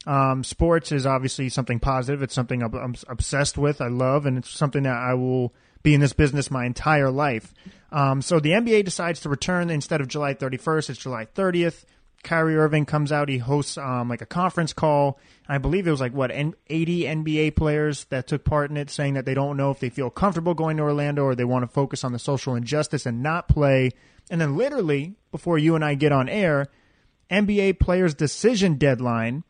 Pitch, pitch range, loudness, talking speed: 145 Hz, 130-160 Hz, -23 LUFS, 210 wpm